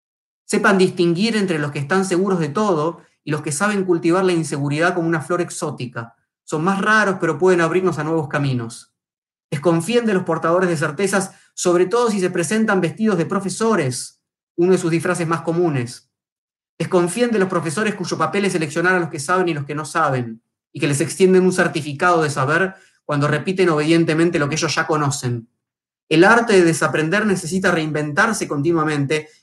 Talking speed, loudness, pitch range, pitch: 180 wpm, -18 LUFS, 155-185 Hz, 170 Hz